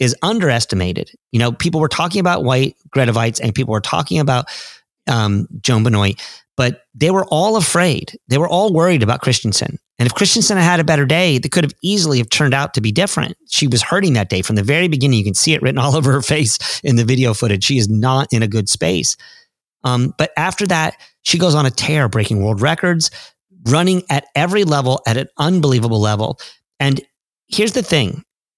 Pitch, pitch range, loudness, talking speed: 140 Hz, 120-170 Hz, -15 LUFS, 210 wpm